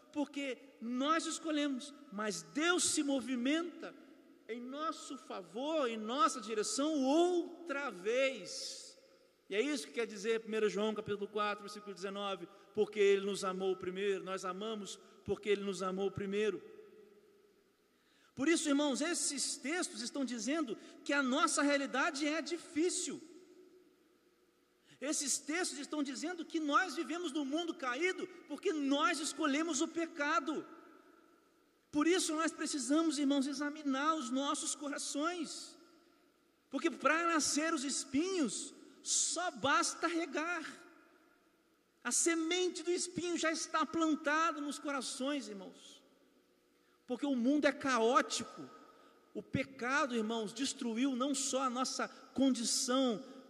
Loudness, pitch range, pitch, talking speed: -36 LUFS, 255-330 Hz, 300 Hz, 120 wpm